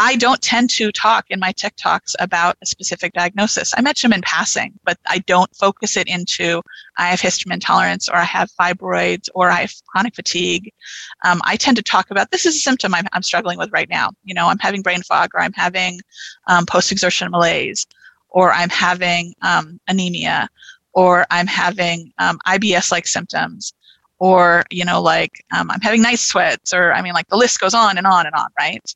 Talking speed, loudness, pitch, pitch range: 205 wpm, -16 LUFS, 185 Hz, 175-210 Hz